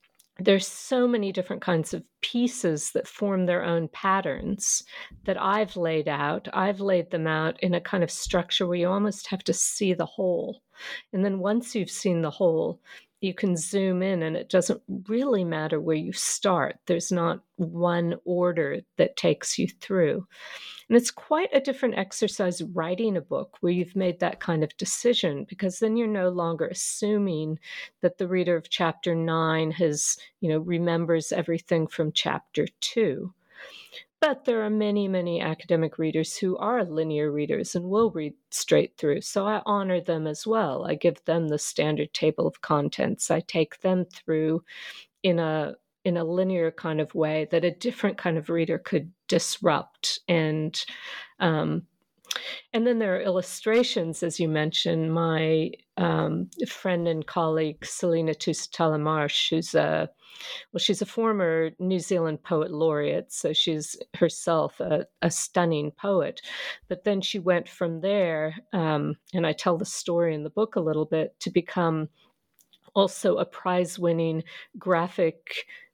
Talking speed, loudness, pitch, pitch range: 160 wpm, -26 LUFS, 180 Hz, 160-205 Hz